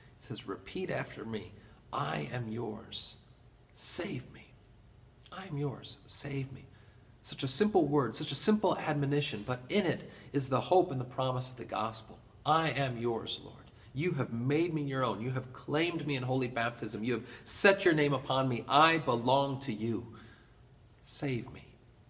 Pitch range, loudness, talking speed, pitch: 115-140 Hz, -32 LUFS, 175 wpm, 125 Hz